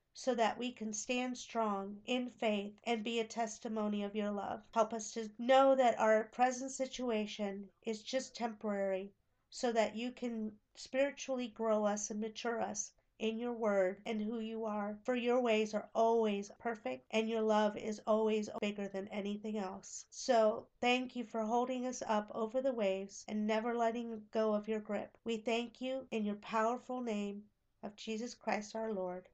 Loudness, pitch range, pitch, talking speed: -37 LUFS, 210-240 Hz, 225 Hz, 180 wpm